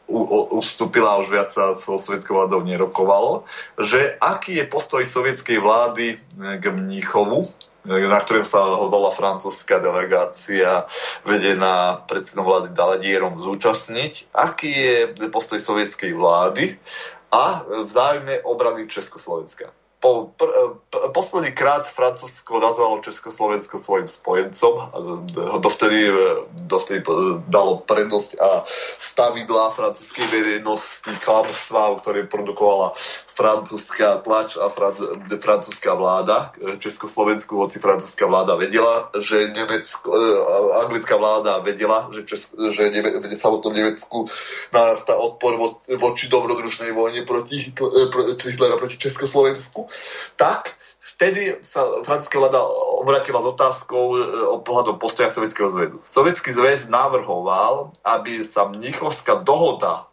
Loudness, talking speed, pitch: -20 LUFS, 120 wpm, 115 Hz